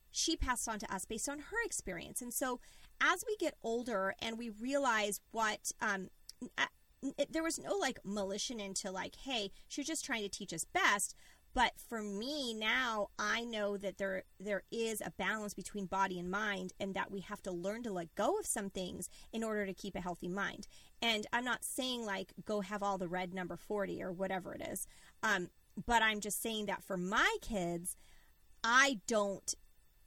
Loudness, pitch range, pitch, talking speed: -37 LUFS, 195-235 Hz, 210 Hz, 200 wpm